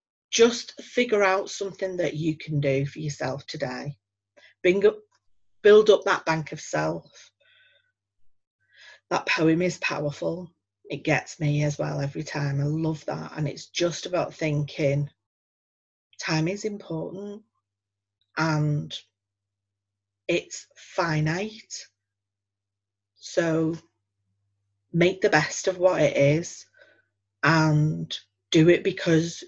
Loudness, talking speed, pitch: -25 LUFS, 115 wpm, 155 Hz